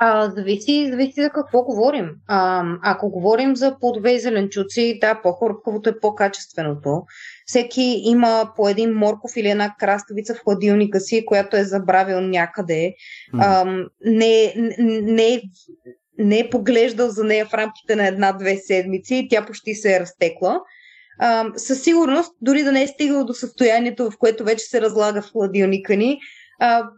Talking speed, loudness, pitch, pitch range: 155 wpm, -19 LUFS, 220 Hz, 200-245 Hz